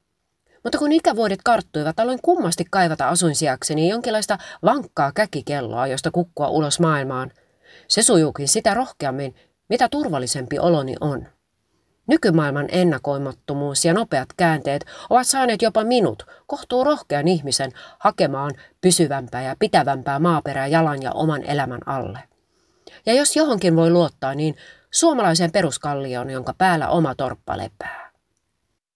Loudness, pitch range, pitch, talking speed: -20 LUFS, 140-215 Hz, 165 Hz, 120 wpm